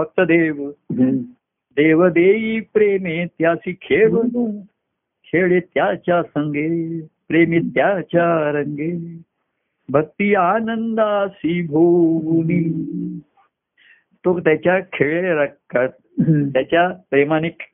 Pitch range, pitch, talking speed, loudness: 160-195 Hz, 170 Hz, 75 wpm, -18 LUFS